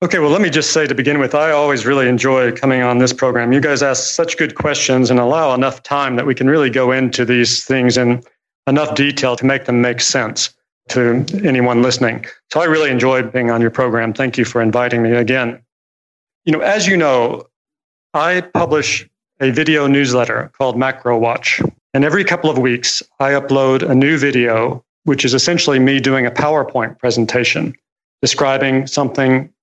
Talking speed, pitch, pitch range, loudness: 190 wpm, 130 Hz, 125-145 Hz, -14 LUFS